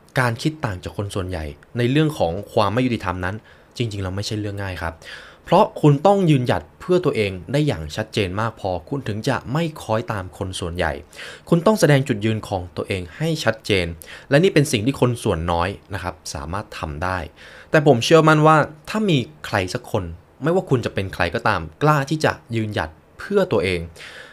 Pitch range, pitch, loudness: 90-140 Hz, 110 Hz, -21 LUFS